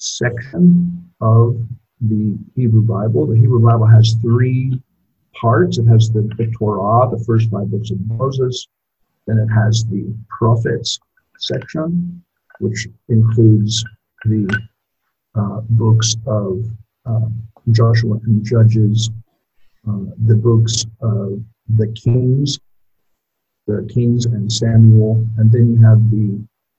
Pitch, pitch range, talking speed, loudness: 115 Hz, 110-120 Hz, 115 wpm, -15 LUFS